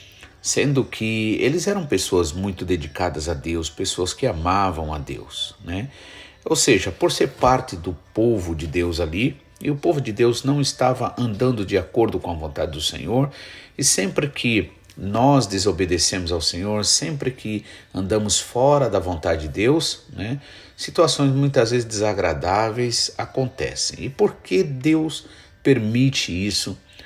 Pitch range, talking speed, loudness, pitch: 95-130 Hz, 150 wpm, -21 LUFS, 105 Hz